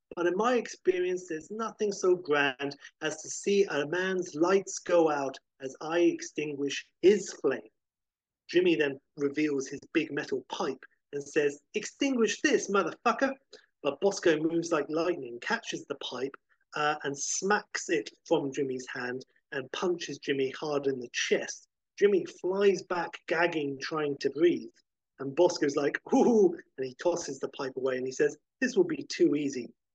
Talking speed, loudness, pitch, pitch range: 160 wpm, -30 LUFS, 165 Hz, 140-215 Hz